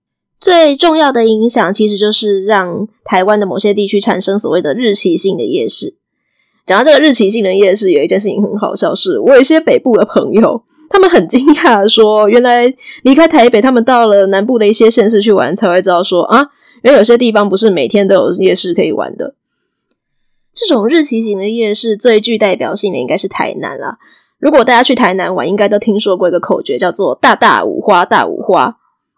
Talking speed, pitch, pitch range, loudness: 320 characters per minute, 220 Hz, 200-255 Hz, -10 LUFS